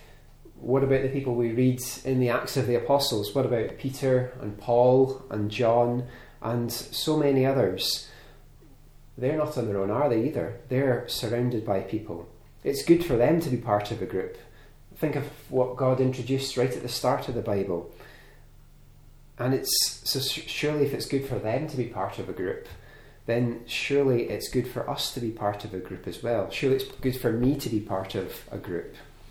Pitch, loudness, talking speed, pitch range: 125 Hz, -27 LUFS, 200 wpm, 120-135 Hz